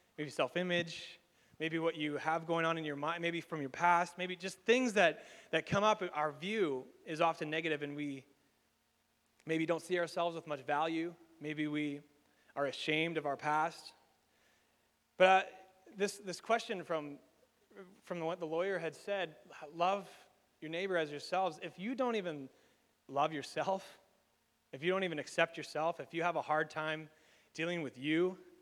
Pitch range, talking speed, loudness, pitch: 155-185 Hz, 170 wpm, -36 LUFS, 165 Hz